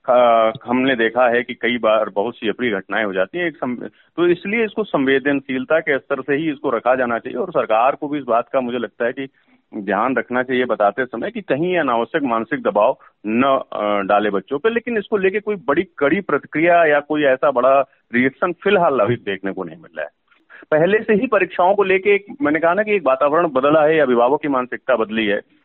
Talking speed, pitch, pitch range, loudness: 215 wpm, 135 Hz, 120-175 Hz, -18 LUFS